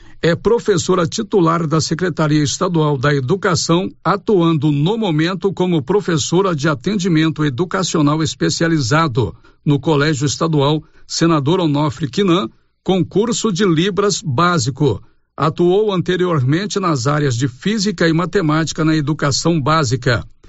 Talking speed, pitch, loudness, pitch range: 110 wpm, 165 Hz, -16 LUFS, 150-185 Hz